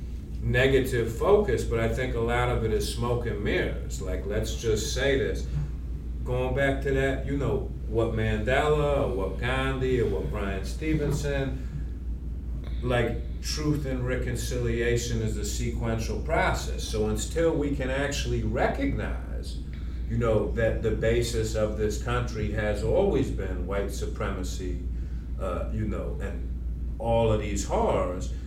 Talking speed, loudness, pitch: 145 wpm, -28 LUFS, 110 Hz